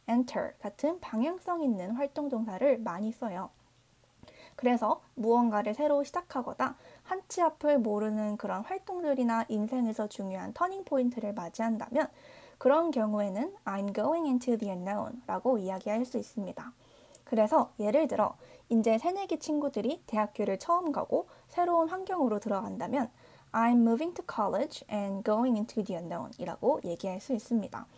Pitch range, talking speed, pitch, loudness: 215-300 Hz, 410 characters per minute, 235 Hz, -31 LUFS